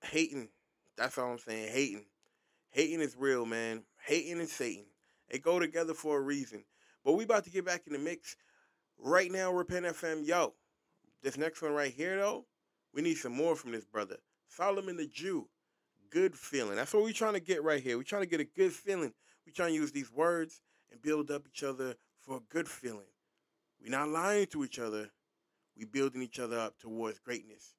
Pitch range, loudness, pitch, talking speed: 125-175 Hz, -35 LUFS, 155 Hz, 205 wpm